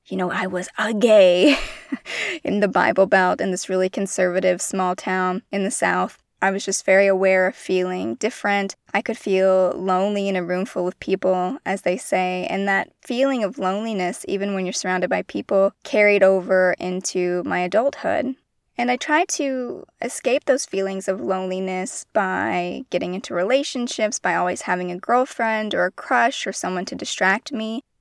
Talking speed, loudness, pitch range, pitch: 175 wpm, -21 LUFS, 185-230 Hz, 195 Hz